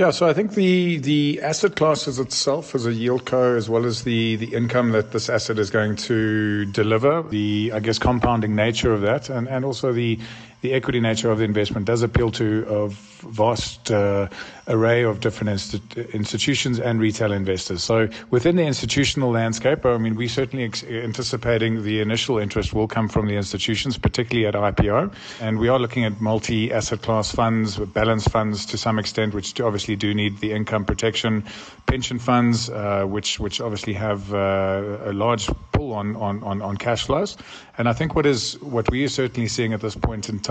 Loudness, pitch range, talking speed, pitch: -22 LUFS, 105-125 Hz, 195 wpm, 115 Hz